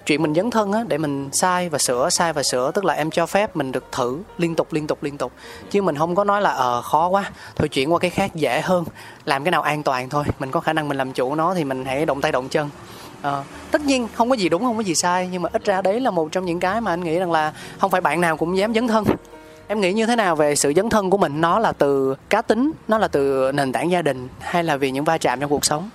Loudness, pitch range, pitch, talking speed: -20 LUFS, 145-195 Hz, 165 Hz, 305 wpm